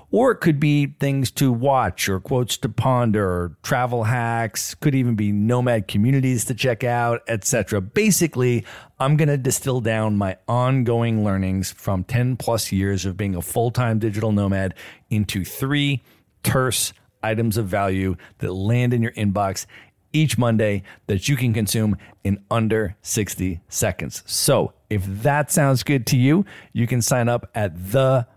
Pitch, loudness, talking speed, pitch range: 115 Hz, -21 LUFS, 160 wpm, 100-130 Hz